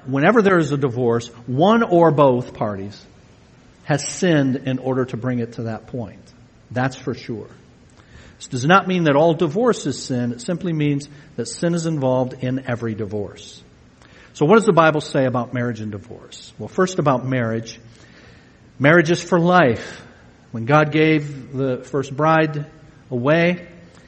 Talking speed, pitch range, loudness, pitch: 165 wpm, 120-160 Hz, -19 LUFS, 135 Hz